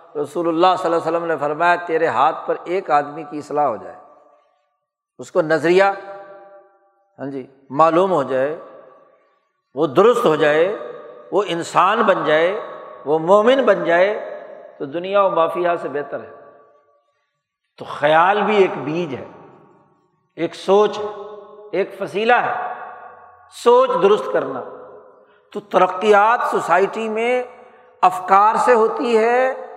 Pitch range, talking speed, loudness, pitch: 165-250 Hz, 135 wpm, -17 LUFS, 195 Hz